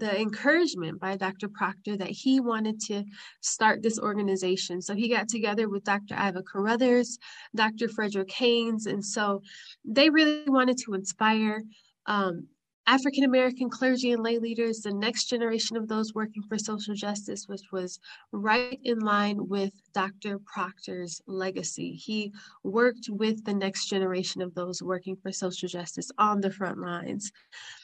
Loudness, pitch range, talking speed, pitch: -28 LUFS, 195-230 Hz, 155 wpm, 210 Hz